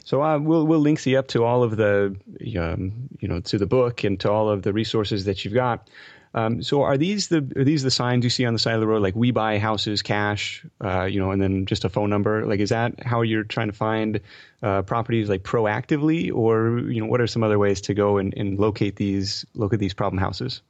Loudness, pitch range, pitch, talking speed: -22 LUFS, 100-125 Hz, 110 Hz, 250 wpm